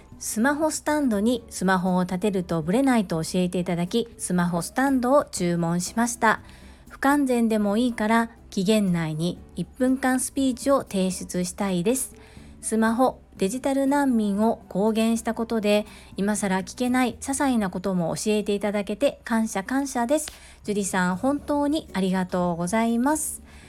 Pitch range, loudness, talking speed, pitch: 190-255 Hz, -24 LUFS, 325 characters per minute, 220 Hz